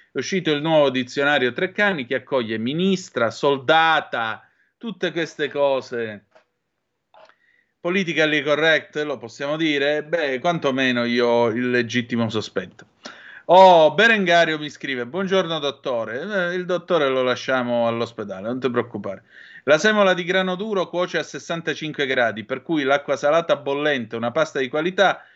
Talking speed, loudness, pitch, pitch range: 135 wpm, -20 LUFS, 145 Hz, 125-175 Hz